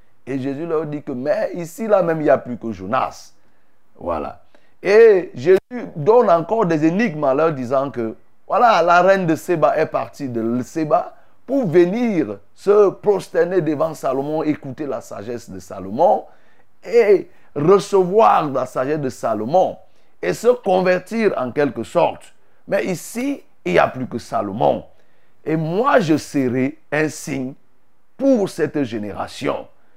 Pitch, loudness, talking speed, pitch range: 160 Hz, -18 LUFS, 150 wpm, 135-200 Hz